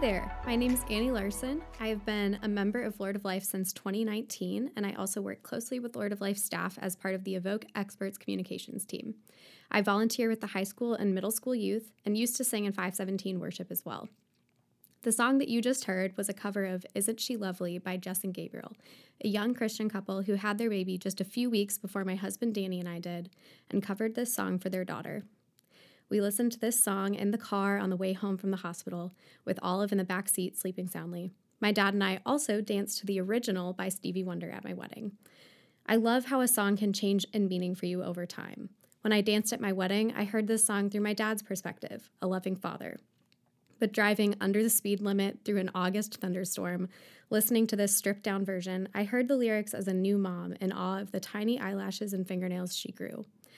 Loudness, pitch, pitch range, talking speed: -32 LUFS, 200 Hz, 190-220 Hz, 225 wpm